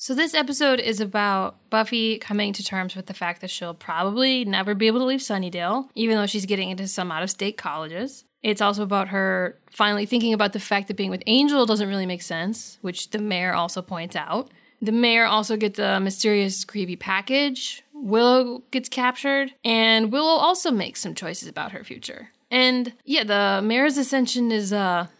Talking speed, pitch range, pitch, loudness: 195 wpm, 195-250 Hz, 215 Hz, -23 LUFS